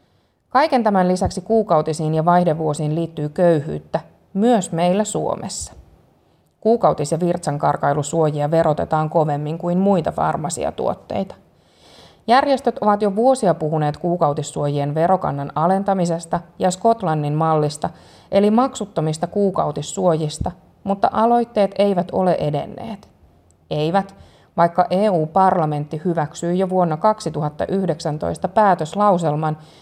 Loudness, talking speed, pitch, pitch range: -19 LUFS, 95 wpm, 170 Hz, 155-195 Hz